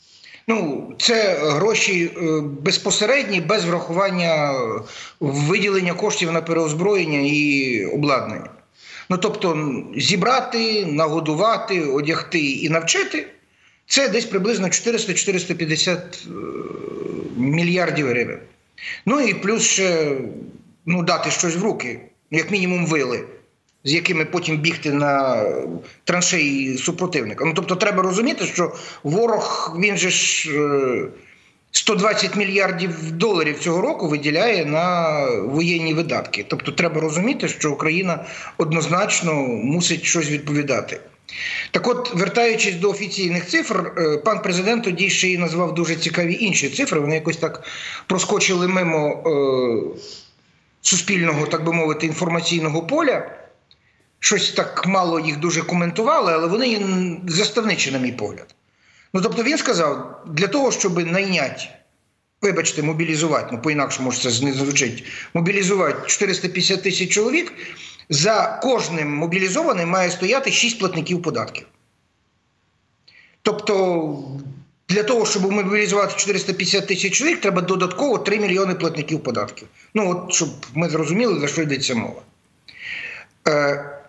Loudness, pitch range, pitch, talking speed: -19 LUFS, 155-200 Hz, 175 Hz, 115 wpm